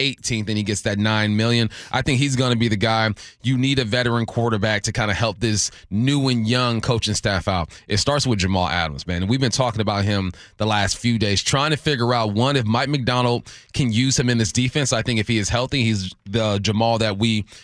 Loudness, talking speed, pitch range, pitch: -20 LUFS, 240 wpm, 105-125 Hz, 115 Hz